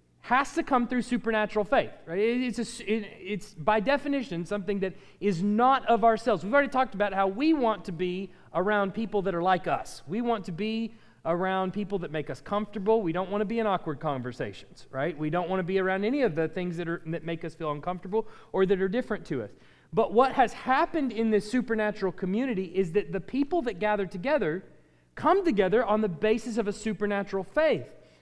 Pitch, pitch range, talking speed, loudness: 205 Hz, 185-230 Hz, 215 wpm, -28 LUFS